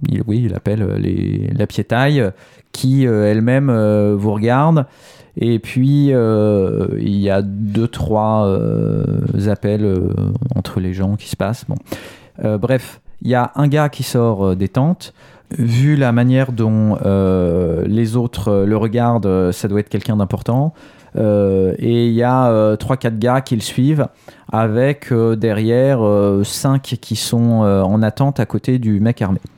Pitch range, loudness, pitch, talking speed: 105-130 Hz, -16 LUFS, 115 Hz, 170 wpm